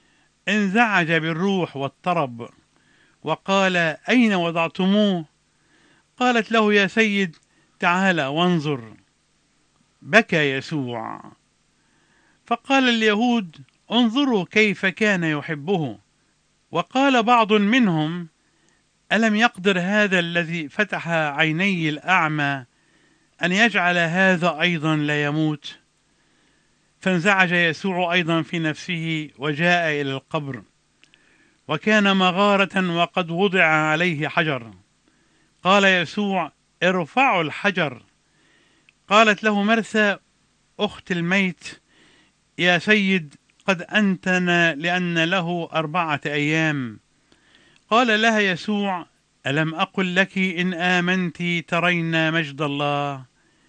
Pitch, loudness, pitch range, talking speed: 175 Hz, -20 LUFS, 155-200 Hz, 85 wpm